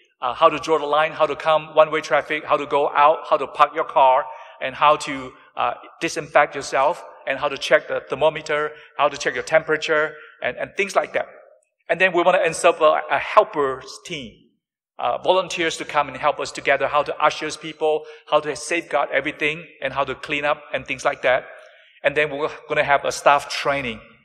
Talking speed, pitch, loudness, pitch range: 215 wpm, 155 Hz, -20 LUFS, 145-160 Hz